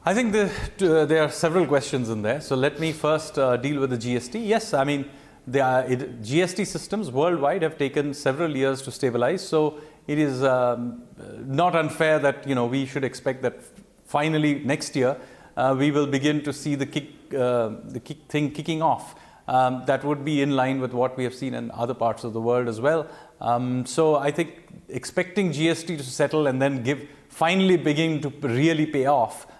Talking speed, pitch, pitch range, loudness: 205 wpm, 145 Hz, 130-155 Hz, -24 LUFS